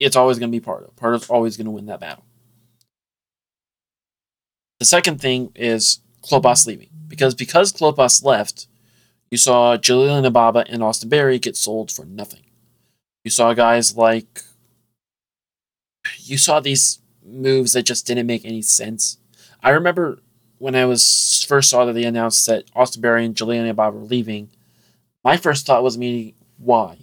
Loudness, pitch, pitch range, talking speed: -16 LUFS, 120 Hz, 115-130 Hz, 170 wpm